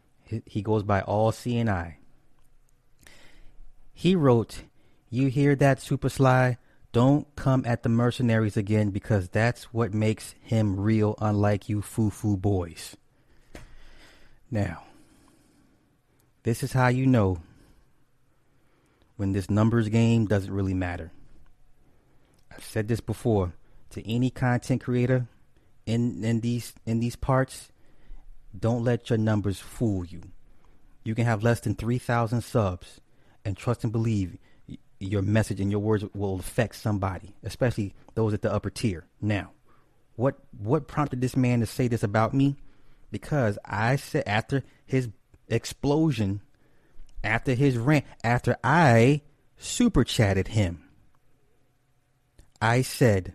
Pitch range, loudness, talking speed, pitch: 105-130 Hz, -26 LUFS, 130 wpm, 115 Hz